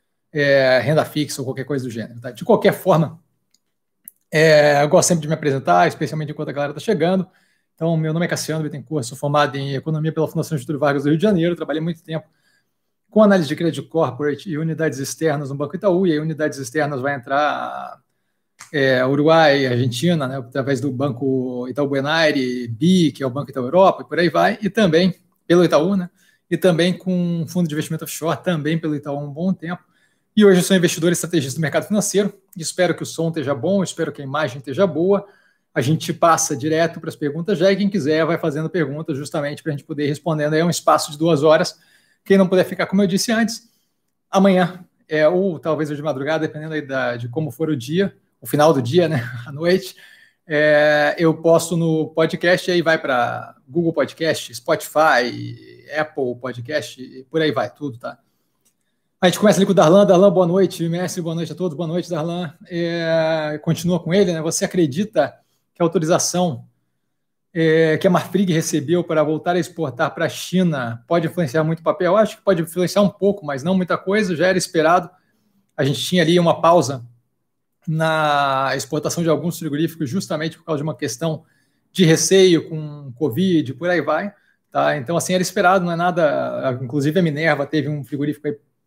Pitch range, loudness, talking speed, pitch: 145-180 Hz, -19 LUFS, 205 wpm, 160 Hz